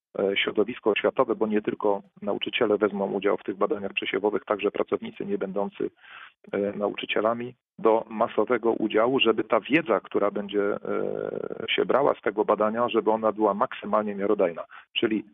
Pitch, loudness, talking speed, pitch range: 110 Hz, -26 LUFS, 140 wpm, 100-120 Hz